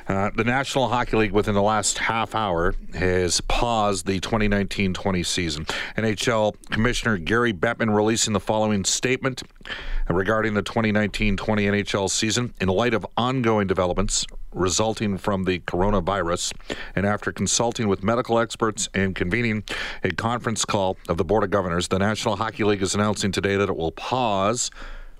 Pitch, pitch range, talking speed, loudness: 105 Hz, 95-115 Hz, 155 wpm, -23 LUFS